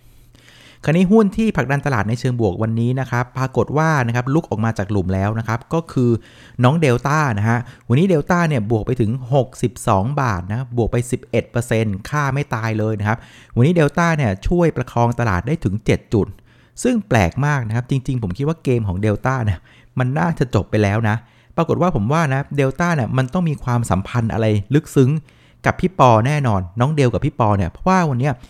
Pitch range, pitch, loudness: 110-145 Hz, 125 Hz, -18 LUFS